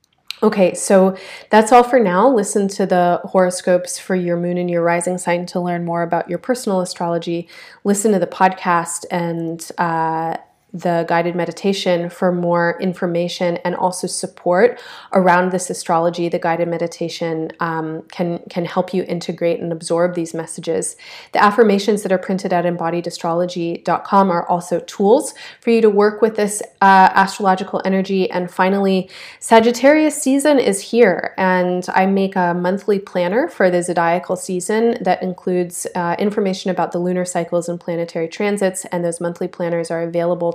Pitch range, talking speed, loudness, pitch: 170-195 Hz, 160 wpm, -17 LUFS, 180 Hz